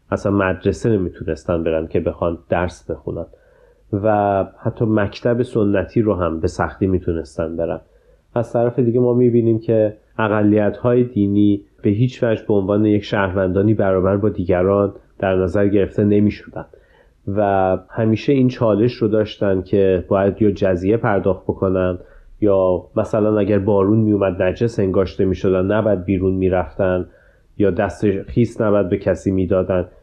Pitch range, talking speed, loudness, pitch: 95-110 Hz, 140 wpm, -18 LUFS, 100 Hz